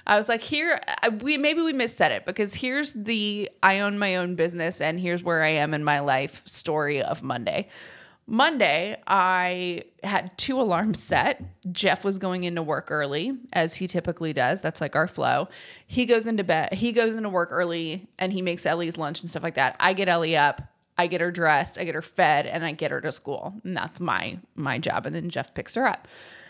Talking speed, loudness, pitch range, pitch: 215 wpm, -25 LUFS, 165-215 Hz, 180 Hz